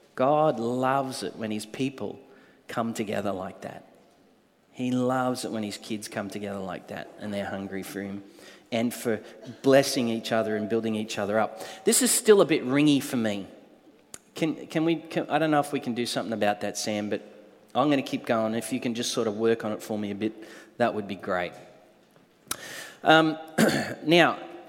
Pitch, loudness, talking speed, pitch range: 115 Hz, -26 LUFS, 200 wpm, 105-130 Hz